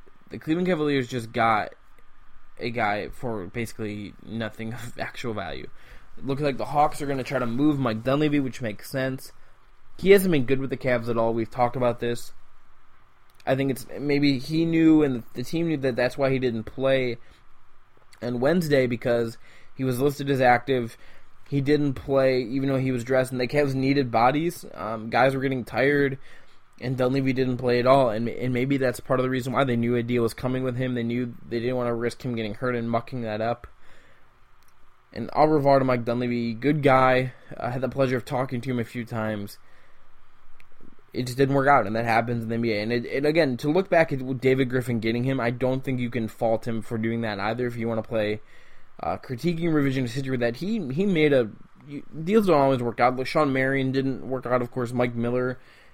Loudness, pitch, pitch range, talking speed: -25 LUFS, 125 Hz, 120-135 Hz, 220 wpm